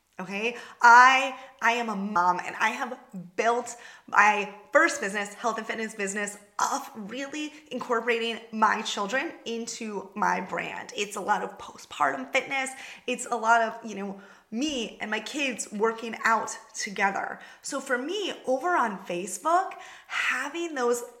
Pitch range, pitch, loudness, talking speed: 210-260 Hz, 230 Hz, -26 LUFS, 145 wpm